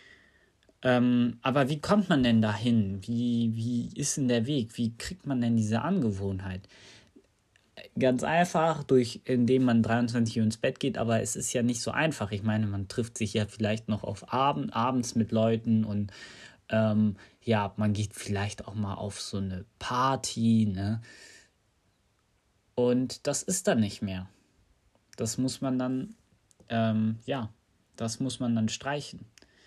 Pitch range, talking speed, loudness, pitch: 105-125 Hz, 160 wpm, -29 LUFS, 115 Hz